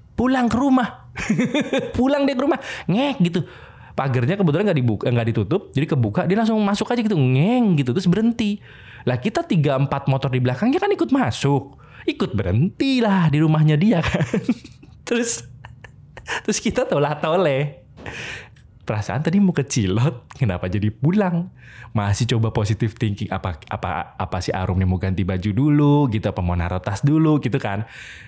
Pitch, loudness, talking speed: 140 Hz, -20 LUFS, 160 wpm